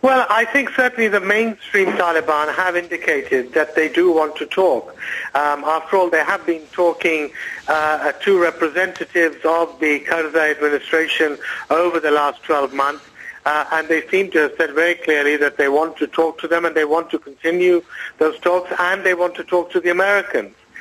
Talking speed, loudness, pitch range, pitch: 185 wpm, -18 LUFS, 155-185 Hz, 165 Hz